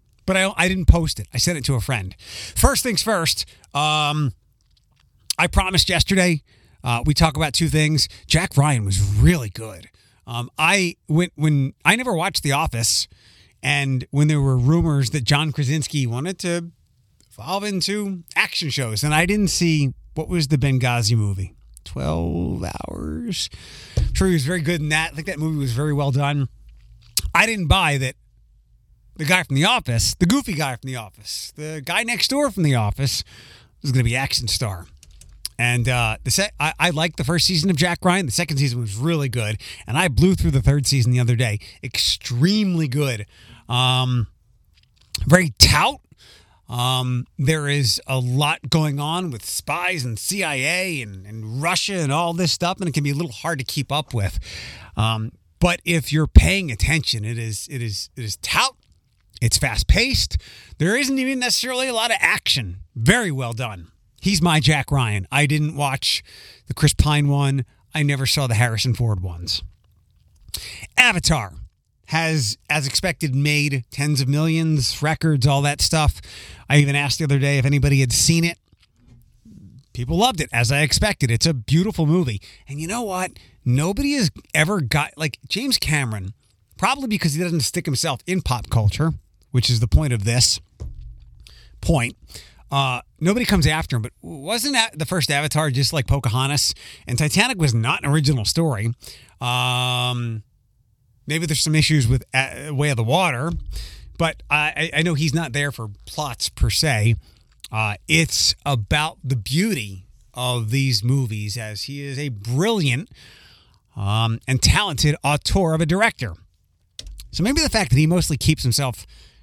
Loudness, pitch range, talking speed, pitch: -20 LUFS, 110-160 Hz, 175 wpm, 135 Hz